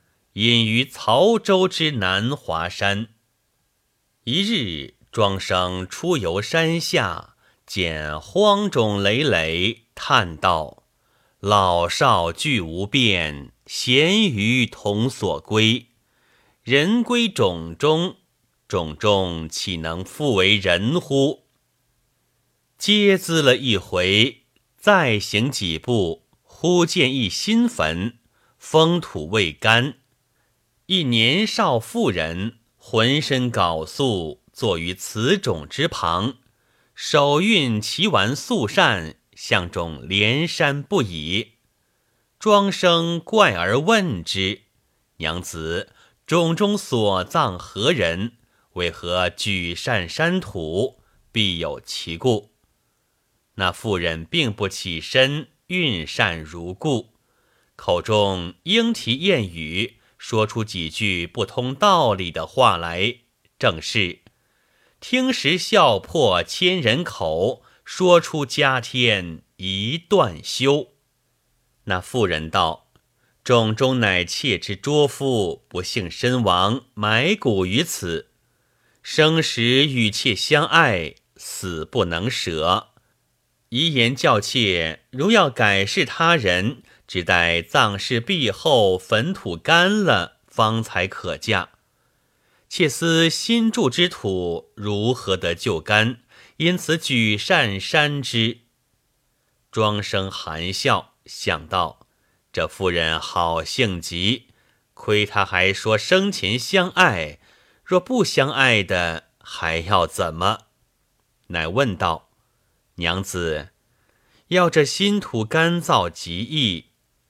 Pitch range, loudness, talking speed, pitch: 95-150 Hz, -20 LUFS, 140 characters per minute, 115 Hz